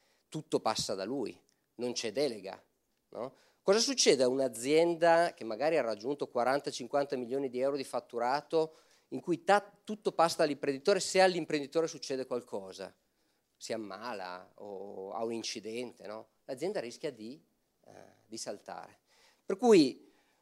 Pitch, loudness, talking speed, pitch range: 140 Hz, -32 LUFS, 140 wpm, 120-165 Hz